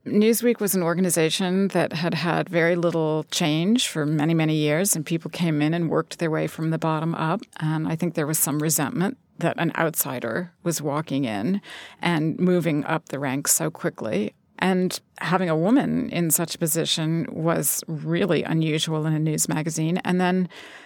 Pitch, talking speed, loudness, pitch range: 165 Hz, 180 wpm, -23 LUFS, 155-180 Hz